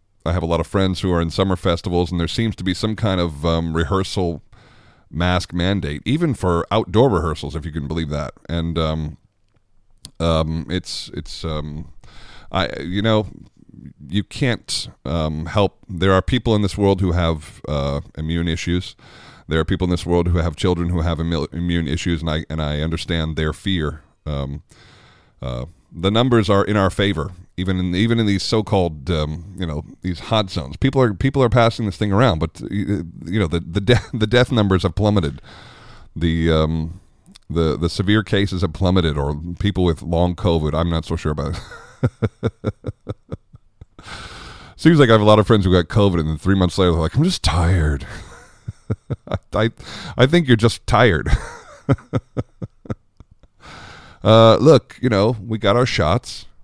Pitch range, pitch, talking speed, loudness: 80-105 Hz, 90 Hz, 180 wpm, -19 LUFS